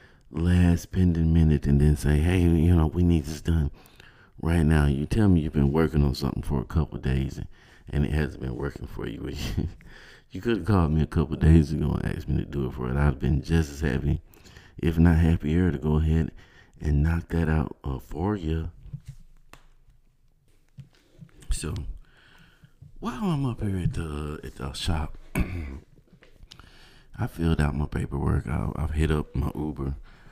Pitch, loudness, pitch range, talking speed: 80 Hz, -26 LUFS, 75-85 Hz, 185 wpm